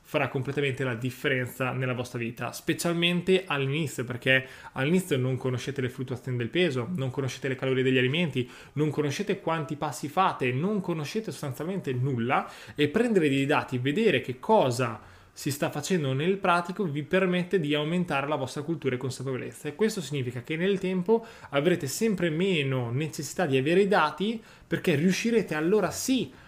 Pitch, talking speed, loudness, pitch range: 150 Hz, 160 wpm, -27 LUFS, 130-180 Hz